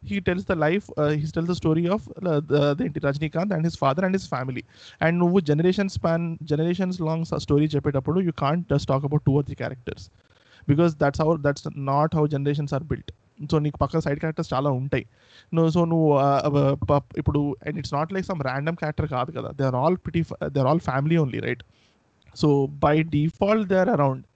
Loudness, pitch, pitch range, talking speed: -24 LUFS, 150 Hz, 140-165 Hz, 185 wpm